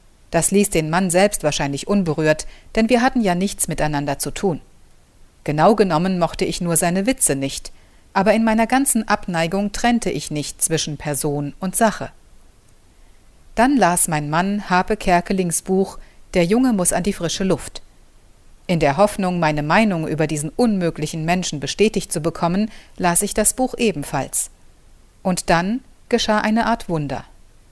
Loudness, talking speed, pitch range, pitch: -19 LUFS, 155 wpm, 150-205 Hz, 175 Hz